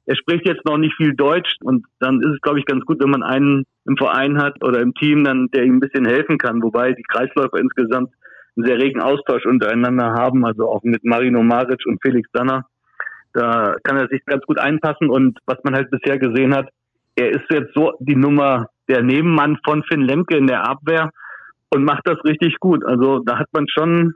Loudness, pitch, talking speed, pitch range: -17 LUFS, 135 Hz, 215 wpm, 125-150 Hz